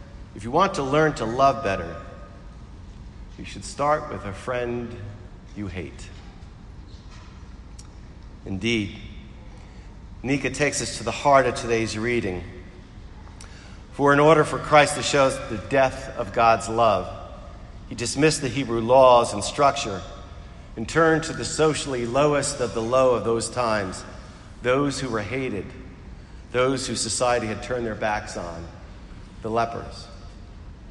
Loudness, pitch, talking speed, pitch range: -22 LUFS, 110 Hz, 140 wpm, 95-130 Hz